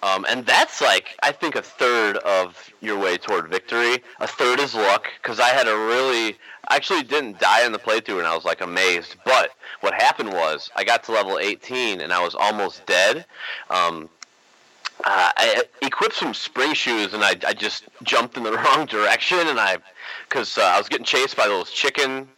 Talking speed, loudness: 205 wpm, -20 LUFS